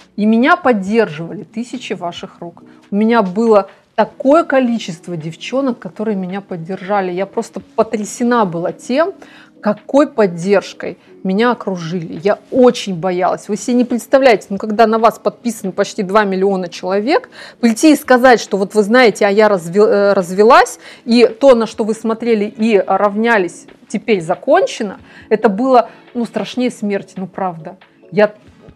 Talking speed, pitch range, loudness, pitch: 140 wpm, 195-235 Hz, -14 LUFS, 215 Hz